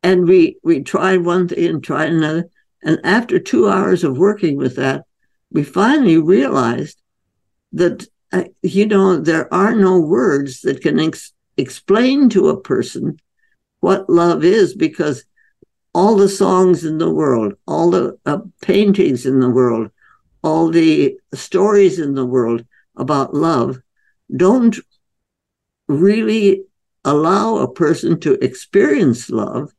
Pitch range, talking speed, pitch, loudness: 145-210 Hz, 135 wpm, 185 Hz, -15 LUFS